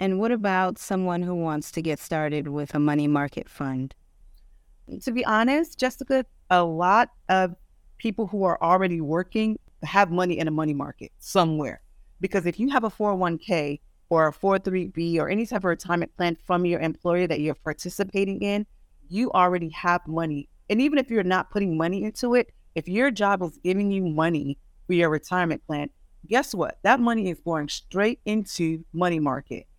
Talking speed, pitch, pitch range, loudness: 180 wpm, 180 Hz, 160-205 Hz, -25 LUFS